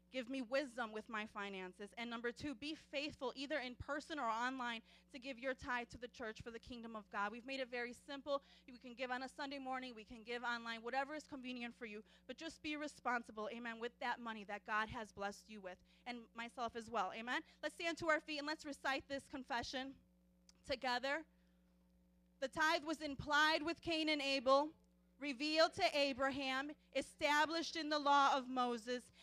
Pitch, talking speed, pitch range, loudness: 255 Hz, 195 wpm, 230-285 Hz, -42 LUFS